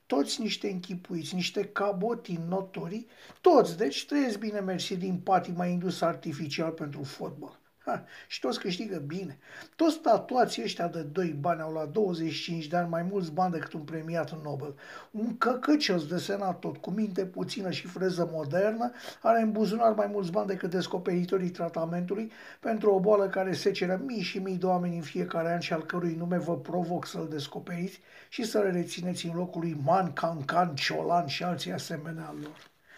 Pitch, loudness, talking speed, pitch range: 180 Hz, -30 LUFS, 180 wpm, 165-200 Hz